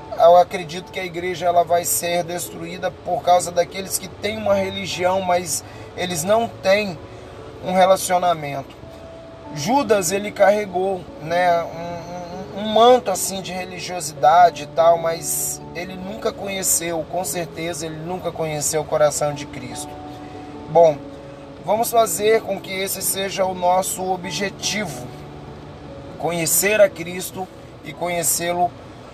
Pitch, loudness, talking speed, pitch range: 175 Hz, -20 LUFS, 130 wpm, 160-190 Hz